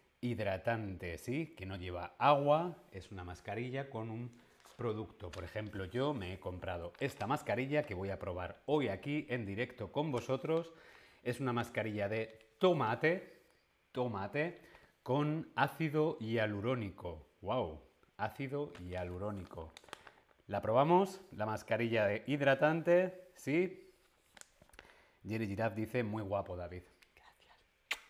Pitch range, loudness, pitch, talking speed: 100-145 Hz, -37 LUFS, 115 Hz, 115 wpm